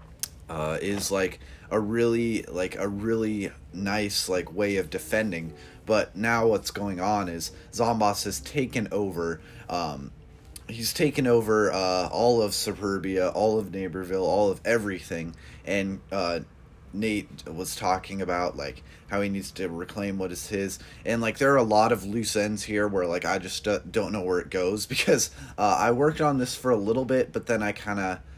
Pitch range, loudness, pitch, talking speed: 90-110 Hz, -27 LUFS, 100 Hz, 185 wpm